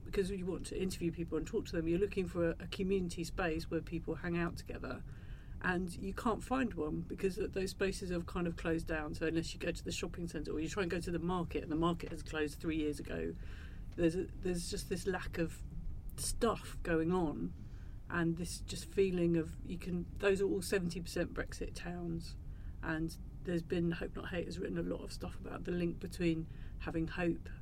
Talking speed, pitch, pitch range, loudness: 215 wpm, 170 Hz, 155-180 Hz, -38 LUFS